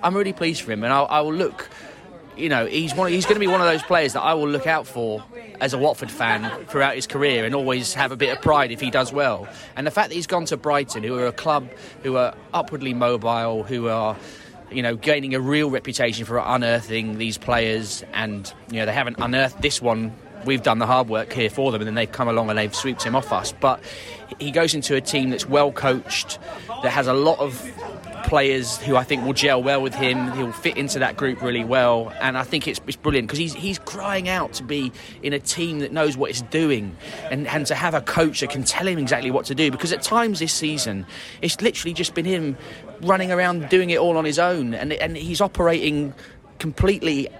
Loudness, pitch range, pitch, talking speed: -22 LUFS, 120-160 Hz, 140 Hz, 240 wpm